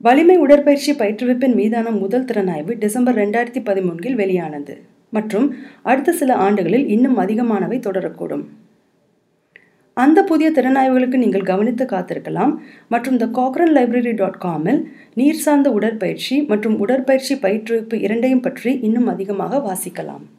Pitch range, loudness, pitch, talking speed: 200-265 Hz, -17 LUFS, 240 Hz, 120 wpm